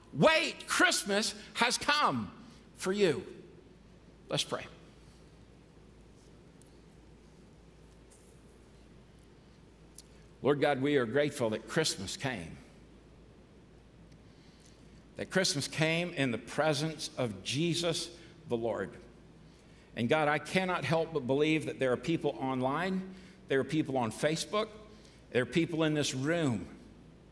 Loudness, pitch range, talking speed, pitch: -31 LUFS, 135-185 Hz, 110 wpm, 155 Hz